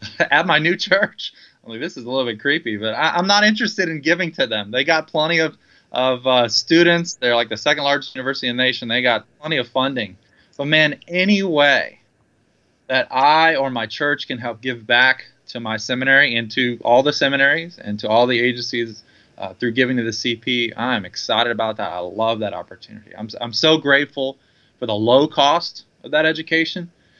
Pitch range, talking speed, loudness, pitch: 120-155 Hz, 205 wpm, -18 LUFS, 130 Hz